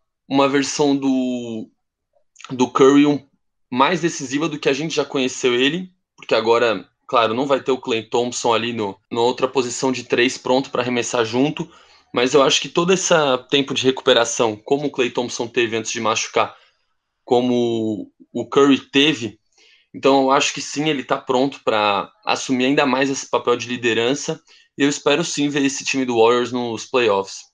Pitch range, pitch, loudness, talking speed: 120-145 Hz, 135 Hz, -19 LUFS, 180 wpm